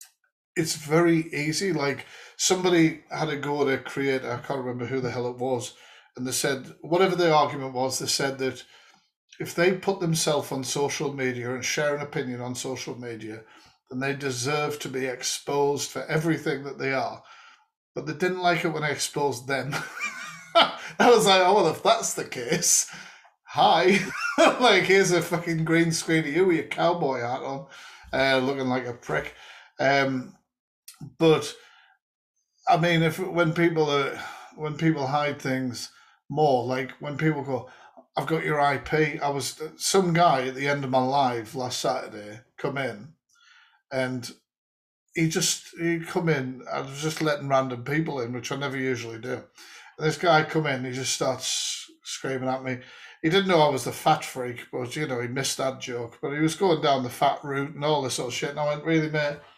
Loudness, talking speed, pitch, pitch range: -25 LUFS, 190 wpm, 145 Hz, 130-165 Hz